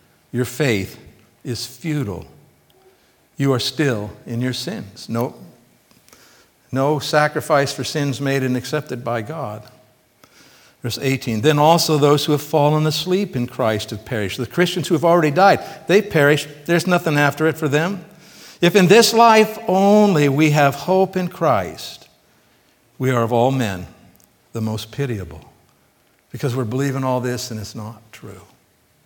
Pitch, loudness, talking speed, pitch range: 140 Hz, -18 LUFS, 155 wpm, 125-165 Hz